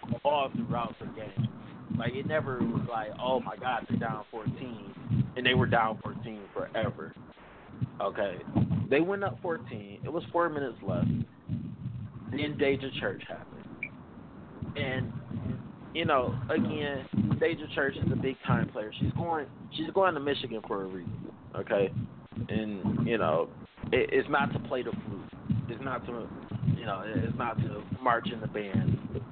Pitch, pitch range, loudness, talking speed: 135 Hz, 115-170 Hz, -32 LUFS, 160 wpm